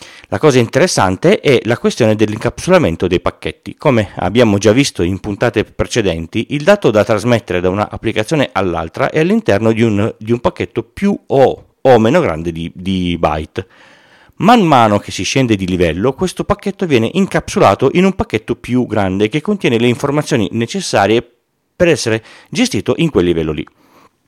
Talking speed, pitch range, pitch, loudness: 165 wpm, 95-150 Hz, 115 Hz, -14 LUFS